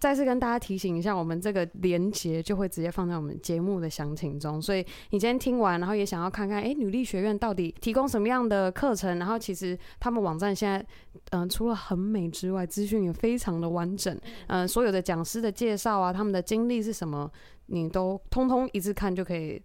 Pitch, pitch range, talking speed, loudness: 195 Hz, 180-220 Hz, 350 characters per minute, -29 LUFS